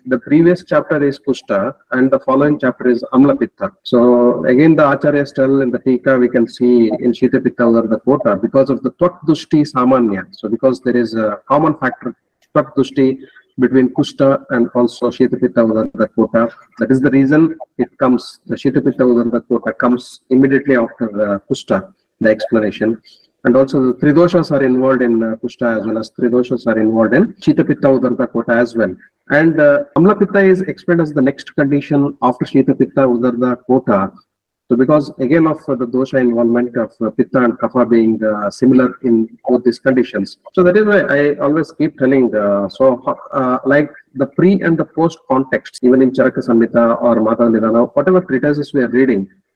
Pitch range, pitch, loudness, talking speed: 120-145 Hz, 130 Hz, -14 LUFS, 180 wpm